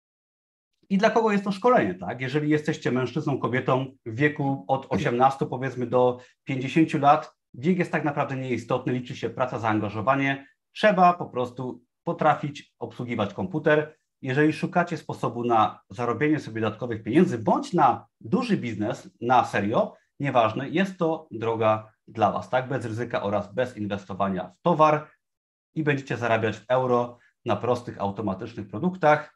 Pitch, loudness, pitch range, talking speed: 130 Hz, -25 LUFS, 115-155 Hz, 145 wpm